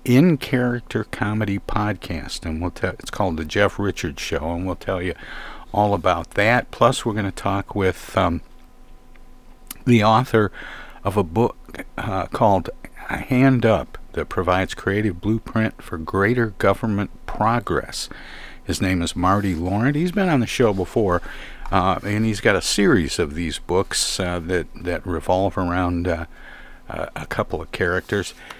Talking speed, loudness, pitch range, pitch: 150 wpm, -21 LUFS, 90-110 Hz, 100 Hz